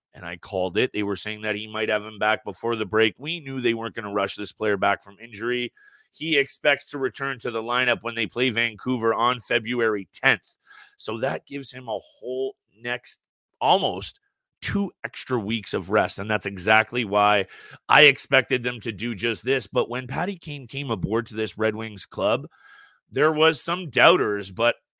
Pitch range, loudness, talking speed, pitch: 110-135 Hz, -24 LUFS, 195 wpm, 115 Hz